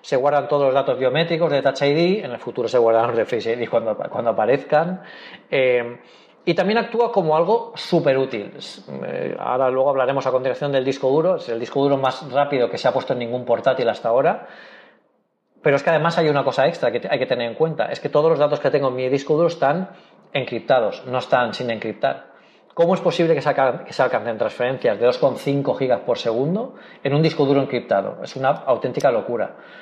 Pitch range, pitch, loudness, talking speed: 130-170 Hz, 140 Hz, -20 LUFS, 210 wpm